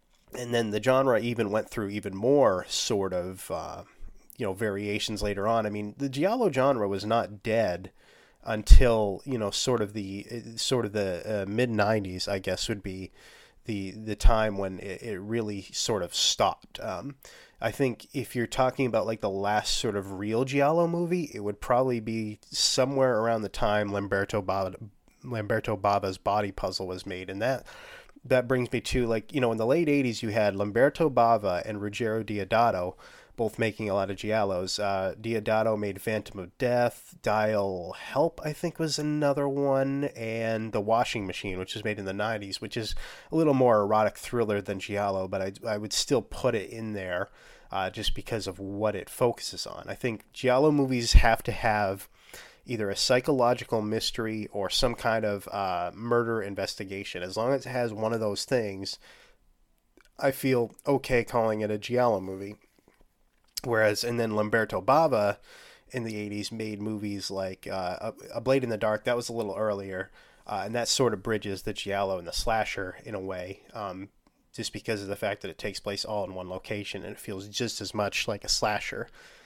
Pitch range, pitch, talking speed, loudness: 100-120 Hz, 110 Hz, 190 wpm, -28 LUFS